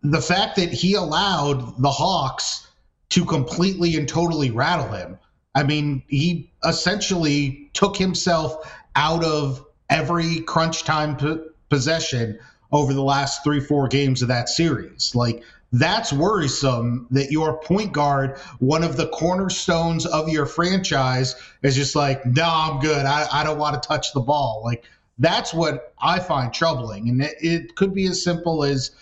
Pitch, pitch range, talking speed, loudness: 150 Hz, 135-165 Hz, 155 wpm, -21 LUFS